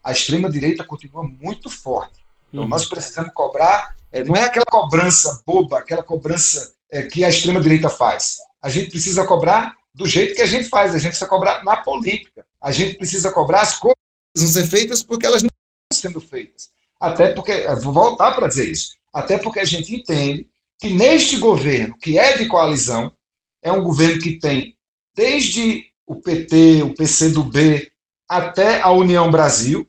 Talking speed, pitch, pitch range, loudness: 175 wpm, 175 Hz, 155-220 Hz, -16 LUFS